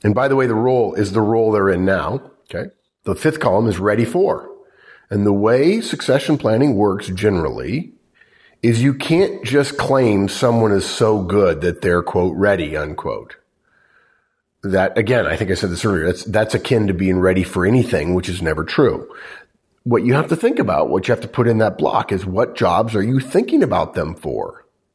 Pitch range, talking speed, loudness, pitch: 95-130 Hz, 200 wpm, -17 LUFS, 110 Hz